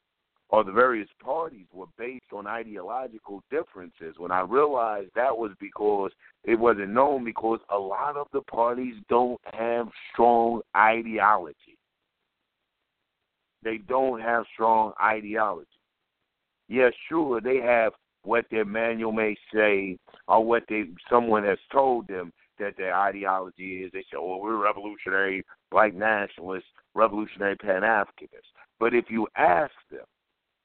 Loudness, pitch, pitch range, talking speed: -25 LUFS, 110 Hz, 100-120 Hz, 135 wpm